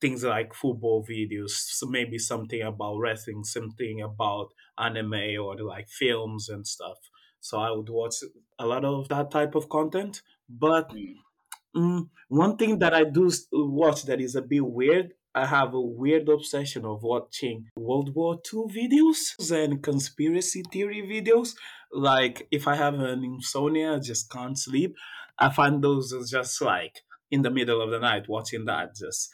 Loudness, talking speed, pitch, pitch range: -27 LUFS, 160 wpm, 130 Hz, 115-155 Hz